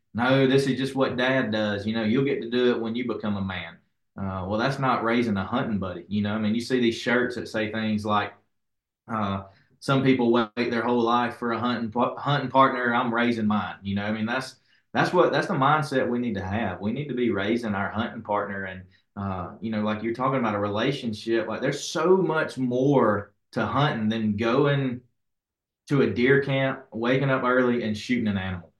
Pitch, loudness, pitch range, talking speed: 115 Hz, -25 LUFS, 105-130 Hz, 220 wpm